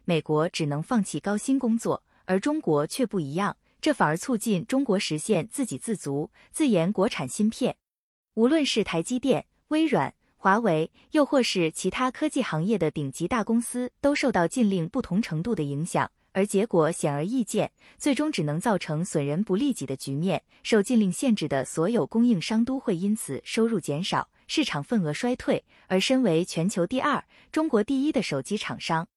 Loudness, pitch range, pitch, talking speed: -26 LUFS, 165-250 Hz, 205 Hz, 280 characters per minute